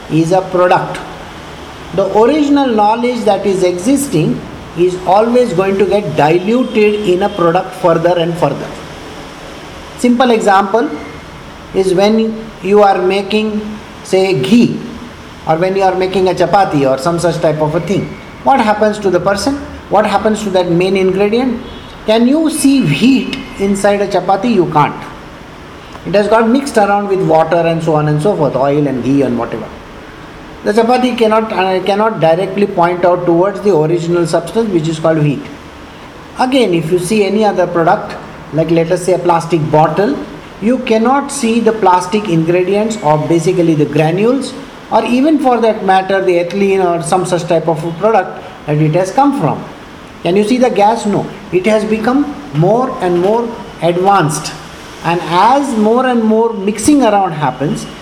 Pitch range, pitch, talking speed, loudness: 170-220 Hz, 195 Hz, 165 wpm, -12 LUFS